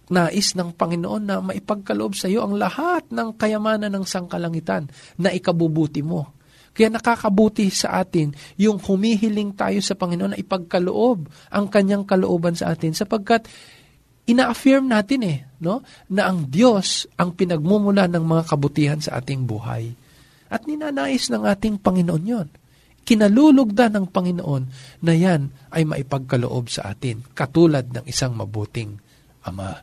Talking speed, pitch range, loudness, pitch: 135 wpm, 145-215 Hz, -20 LUFS, 180 Hz